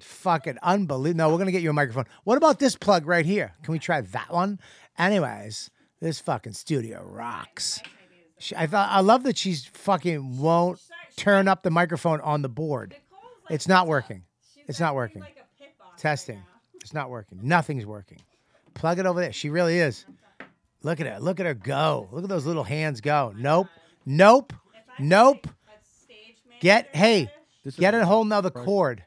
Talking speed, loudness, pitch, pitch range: 170 wpm, -23 LUFS, 170 Hz, 145-195 Hz